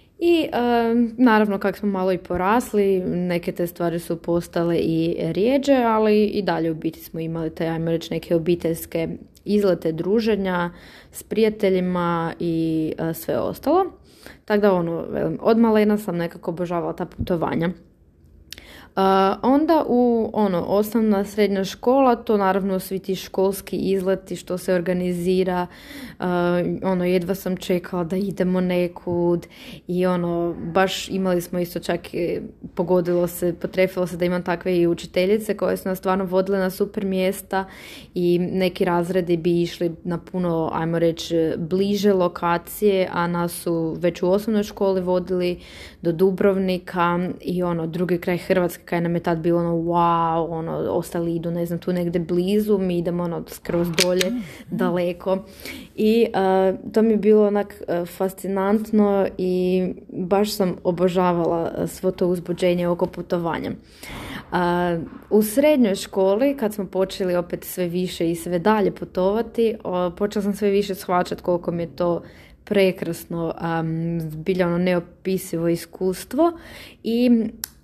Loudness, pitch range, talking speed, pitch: -22 LUFS, 175-195 Hz, 145 wpm, 180 Hz